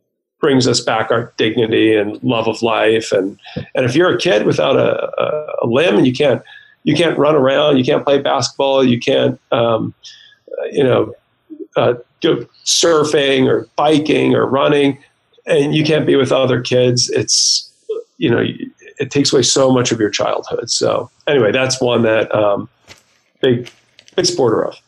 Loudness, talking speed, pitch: -14 LUFS, 170 wpm, 135 Hz